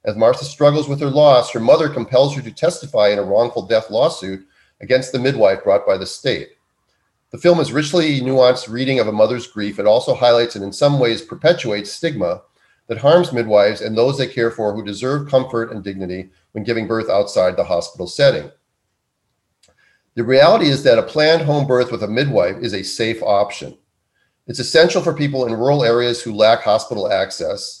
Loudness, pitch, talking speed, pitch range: -16 LUFS, 120 Hz, 190 wpm, 110-145 Hz